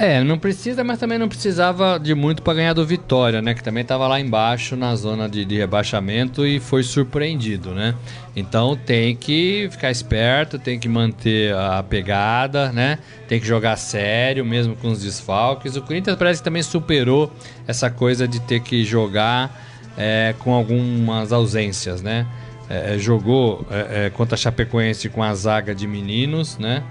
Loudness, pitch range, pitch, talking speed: -20 LUFS, 110-140 Hz, 120 Hz, 170 wpm